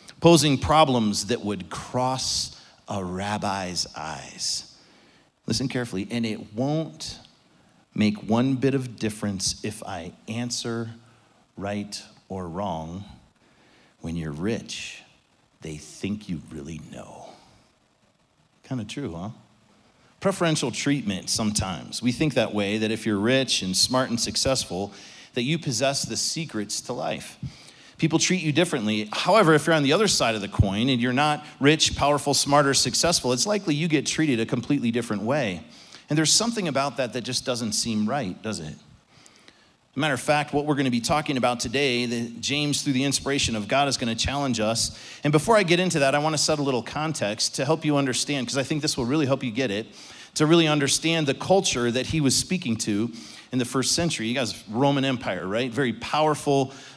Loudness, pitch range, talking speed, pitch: -24 LUFS, 110-145 Hz, 180 wpm, 130 Hz